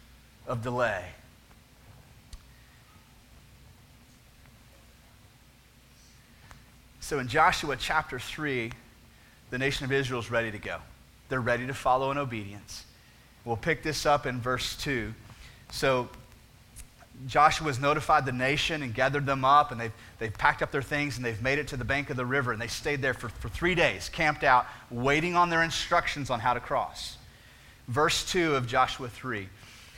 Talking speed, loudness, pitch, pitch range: 155 wpm, -28 LUFS, 125 Hz, 115-140 Hz